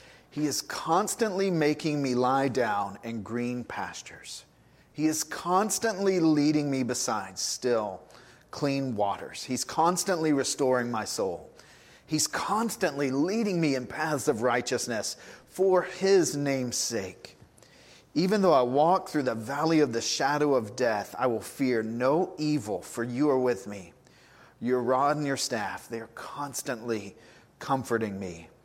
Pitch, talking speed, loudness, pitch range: 140 Hz, 140 wpm, -28 LUFS, 120-160 Hz